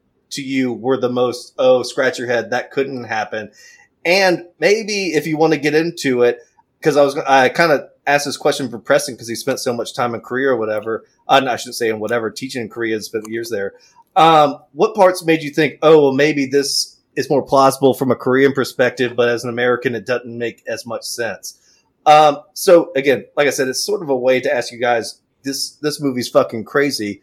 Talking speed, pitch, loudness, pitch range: 225 wpm, 135 Hz, -17 LUFS, 120-150 Hz